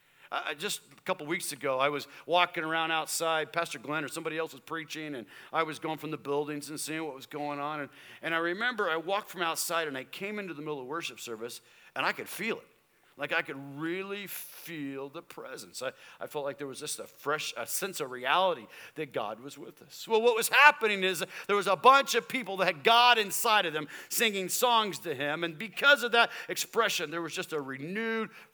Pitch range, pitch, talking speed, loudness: 150-205 Hz, 165 Hz, 230 wpm, -29 LUFS